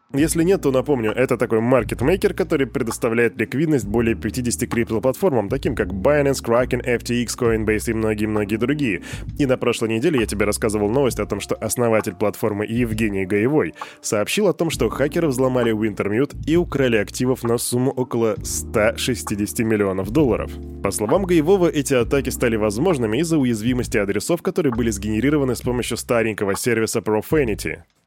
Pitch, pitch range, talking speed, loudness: 120 Hz, 110-135 Hz, 150 wpm, -20 LUFS